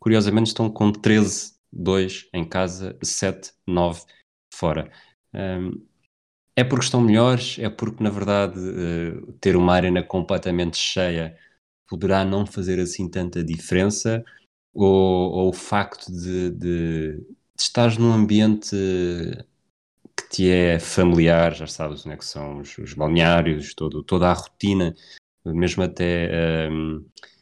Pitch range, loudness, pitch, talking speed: 85-100 Hz, -22 LUFS, 90 Hz, 125 wpm